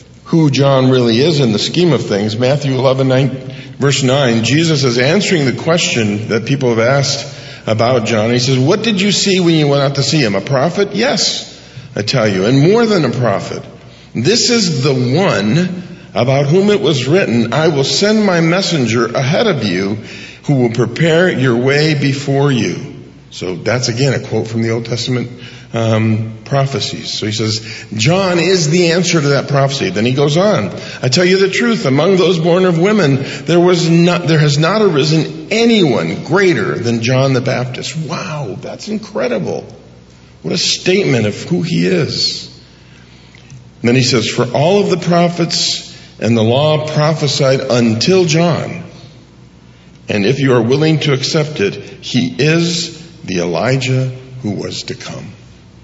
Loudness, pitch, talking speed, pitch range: -13 LUFS, 140 Hz, 175 wpm, 120-170 Hz